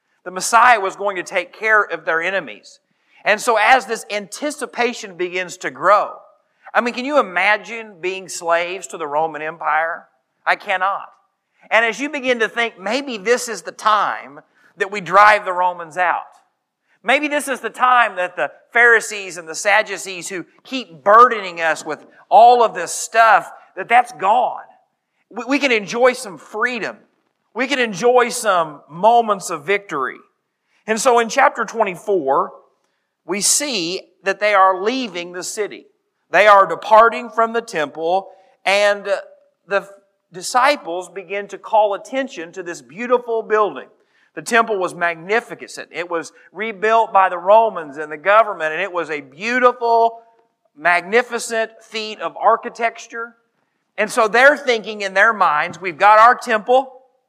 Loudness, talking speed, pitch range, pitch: -17 LUFS, 155 wpm, 185-240 Hz, 215 Hz